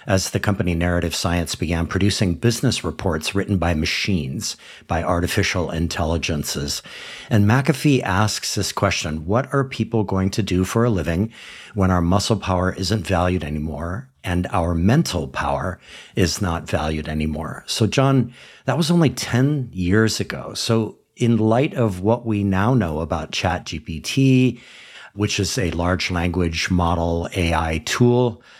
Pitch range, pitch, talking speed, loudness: 85-115 Hz, 95 Hz, 145 wpm, -21 LUFS